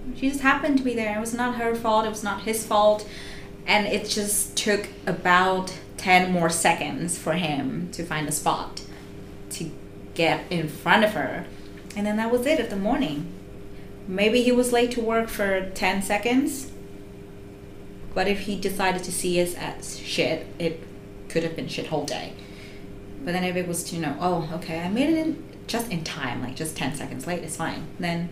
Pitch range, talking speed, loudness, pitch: 145-215 Hz, 200 wpm, -25 LUFS, 180 Hz